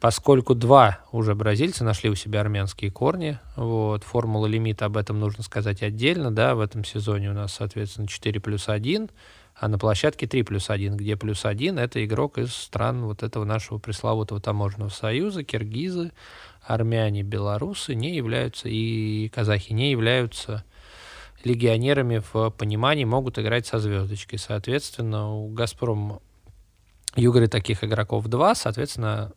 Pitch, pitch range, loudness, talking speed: 110 Hz, 105-120 Hz, -24 LUFS, 145 wpm